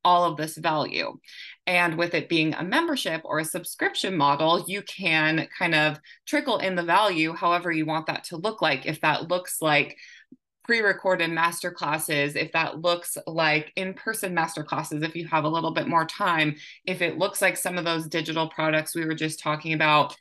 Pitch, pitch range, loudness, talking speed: 165 Hz, 155-180 Hz, -25 LUFS, 195 wpm